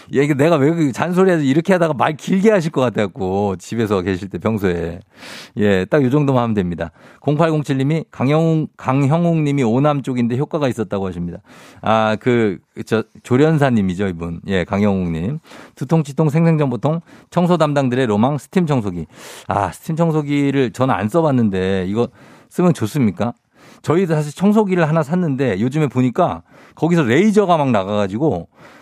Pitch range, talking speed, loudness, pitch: 105-160 Hz, 345 characters per minute, -17 LUFS, 135 Hz